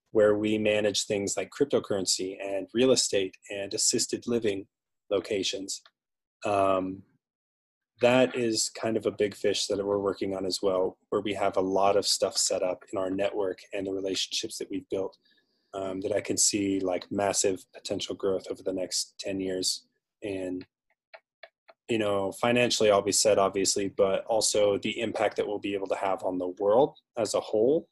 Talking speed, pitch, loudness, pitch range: 180 wpm, 100 Hz, -28 LUFS, 95-105 Hz